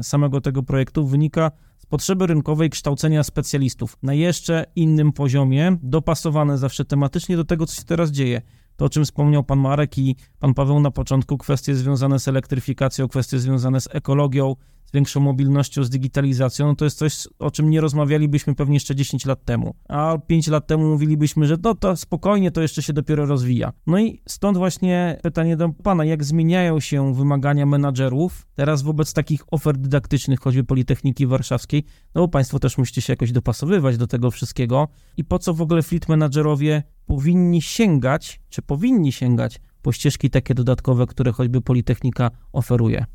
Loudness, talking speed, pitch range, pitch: -20 LUFS, 170 wpm, 135-155 Hz, 145 Hz